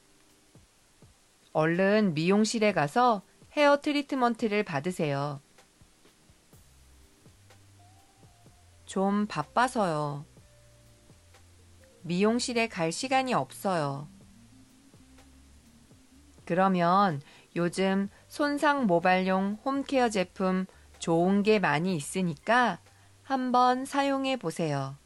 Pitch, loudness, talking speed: 175 Hz, -27 LUFS, 165 characters per minute